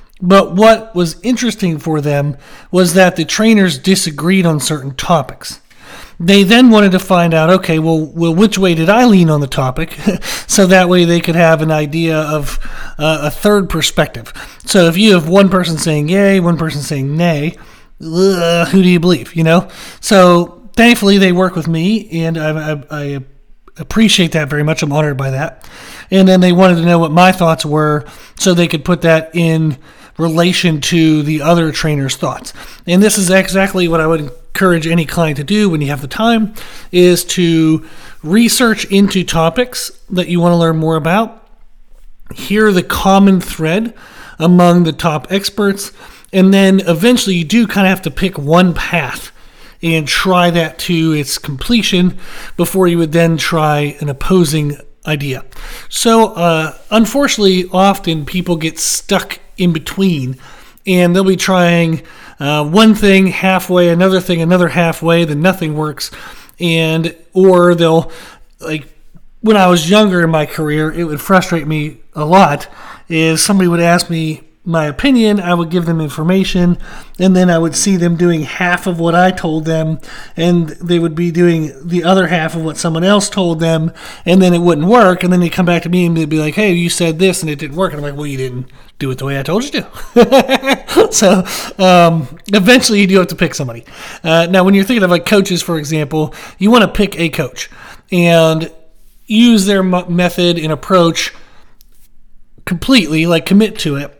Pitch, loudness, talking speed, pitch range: 175 Hz, -12 LUFS, 185 wpm, 160-190 Hz